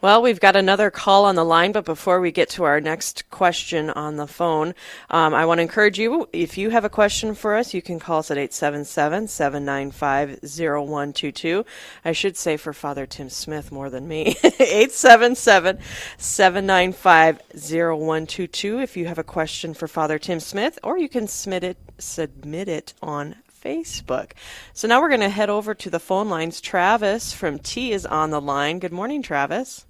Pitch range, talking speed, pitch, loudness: 155-205 Hz, 180 wpm, 170 Hz, -20 LUFS